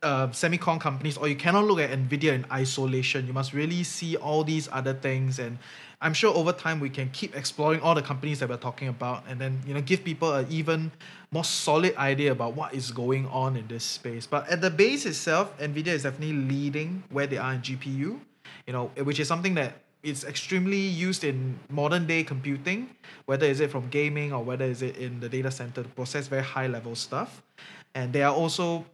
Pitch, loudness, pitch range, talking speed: 145 Hz, -28 LUFS, 130-160 Hz, 215 wpm